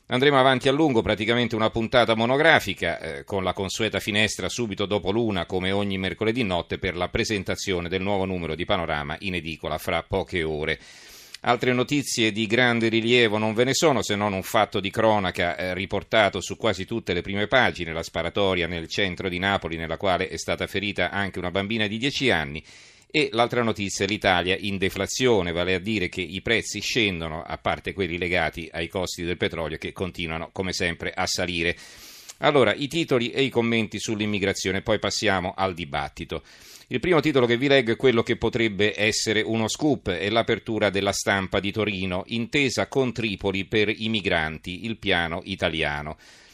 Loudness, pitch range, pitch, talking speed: -24 LUFS, 90-115 Hz, 100 Hz, 180 wpm